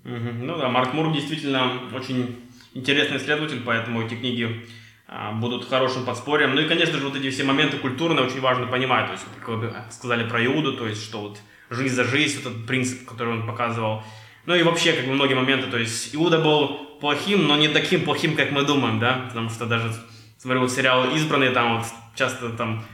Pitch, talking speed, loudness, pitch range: 130 Hz, 200 wpm, -22 LUFS, 115-140 Hz